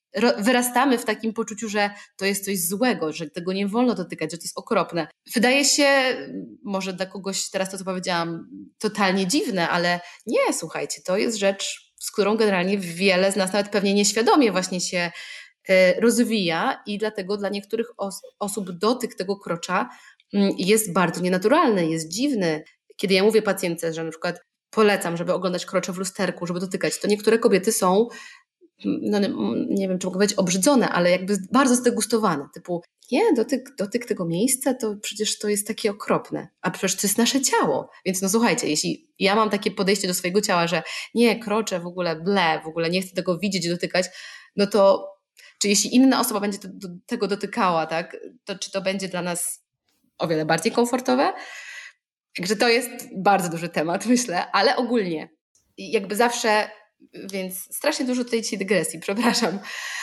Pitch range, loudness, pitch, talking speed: 185-230 Hz, -22 LUFS, 200 Hz, 175 wpm